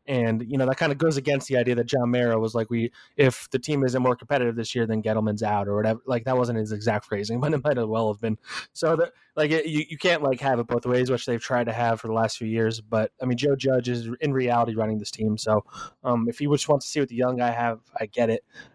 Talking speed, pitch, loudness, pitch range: 290 wpm, 120 Hz, -25 LUFS, 115-135 Hz